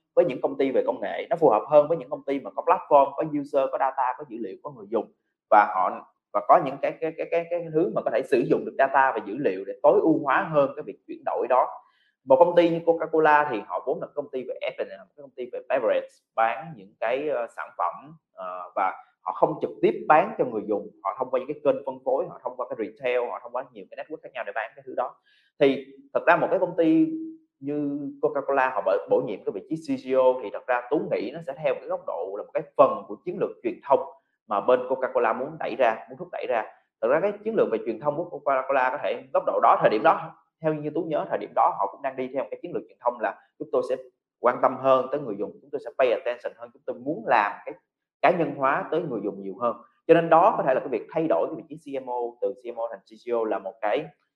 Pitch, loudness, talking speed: 155 Hz, -25 LUFS, 285 wpm